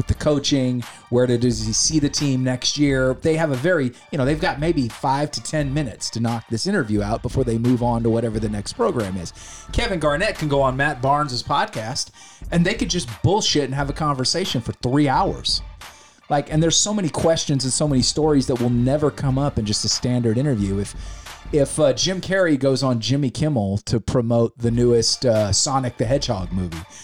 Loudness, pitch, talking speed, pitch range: -20 LUFS, 130 Hz, 215 wpm, 115-150 Hz